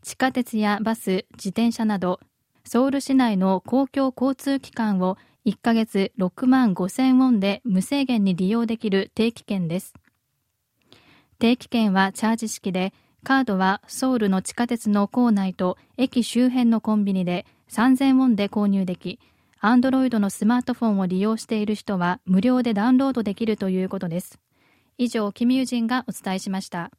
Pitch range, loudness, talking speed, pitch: 195-250 Hz, -22 LUFS, 325 characters per minute, 220 Hz